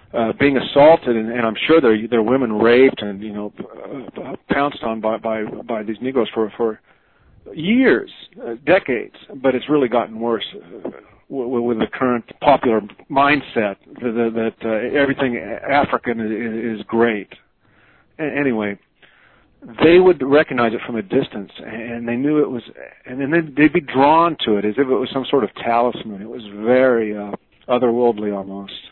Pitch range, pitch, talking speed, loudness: 110-135 Hz, 120 Hz, 170 wpm, -18 LUFS